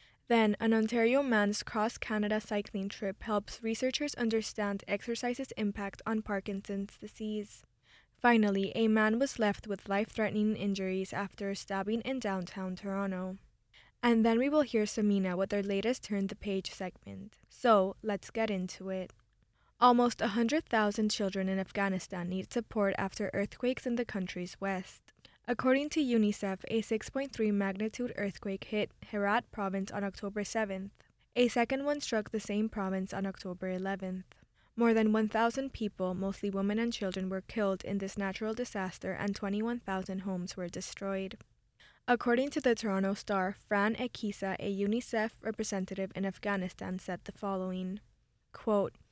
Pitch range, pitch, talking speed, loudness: 195-225 Hz, 205 Hz, 145 wpm, -33 LUFS